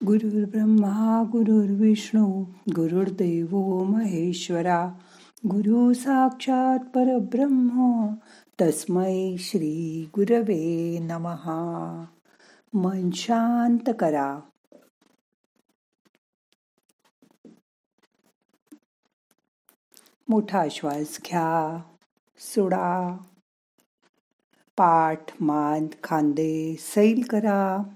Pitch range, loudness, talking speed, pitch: 165-220 Hz, -24 LUFS, 45 wpm, 190 Hz